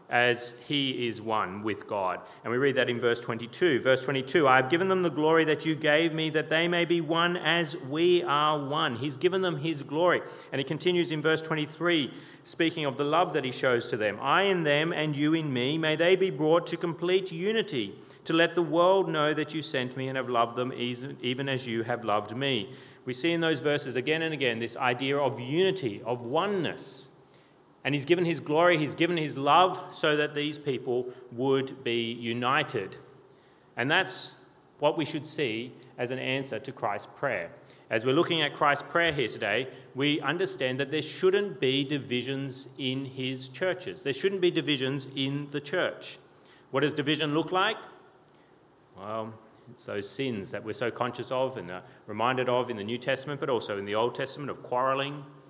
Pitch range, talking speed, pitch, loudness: 130-165 Hz, 200 wpm, 145 Hz, -28 LUFS